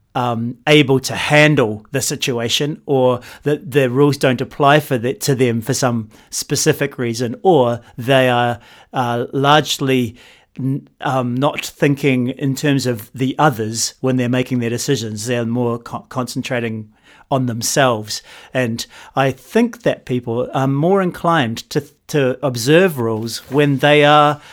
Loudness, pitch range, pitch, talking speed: -17 LUFS, 120-145 Hz, 130 Hz, 150 wpm